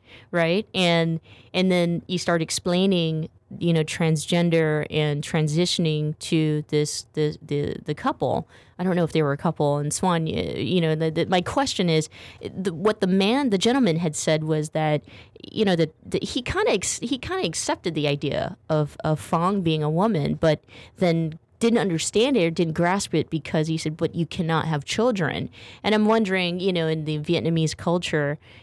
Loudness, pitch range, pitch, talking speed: -23 LUFS, 155-180 Hz, 165 Hz, 195 wpm